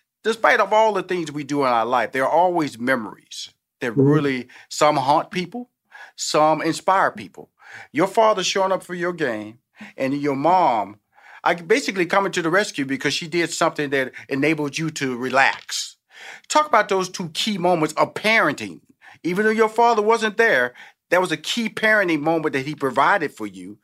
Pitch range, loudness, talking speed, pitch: 140-195 Hz, -20 LUFS, 180 wpm, 165 Hz